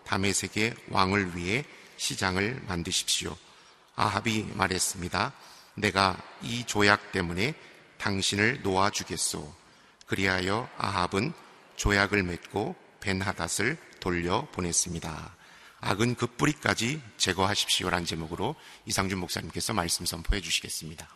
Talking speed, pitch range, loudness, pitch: 285 characters per minute, 90-105 Hz, -28 LUFS, 95 Hz